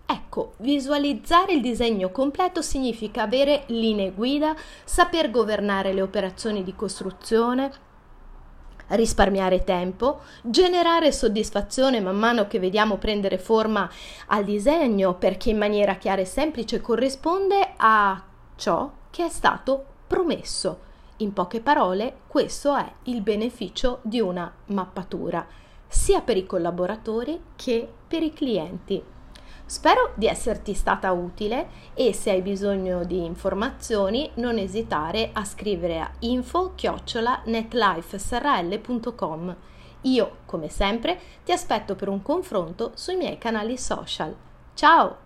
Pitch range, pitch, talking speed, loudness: 195-270 Hz, 225 Hz, 115 wpm, -24 LUFS